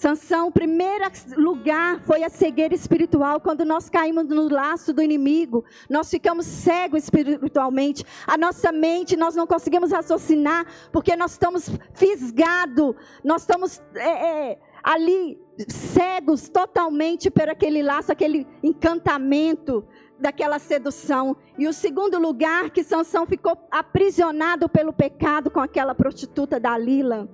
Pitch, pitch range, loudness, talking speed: 325 Hz, 295-345 Hz, -21 LUFS, 130 wpm